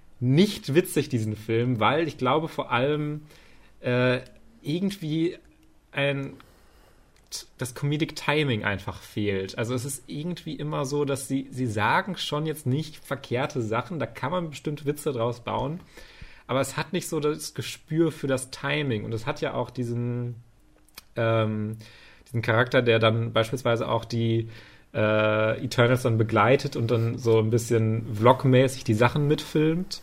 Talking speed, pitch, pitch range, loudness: 150 wpm, 130 Hz, 115-150 Hz, -26 LUFS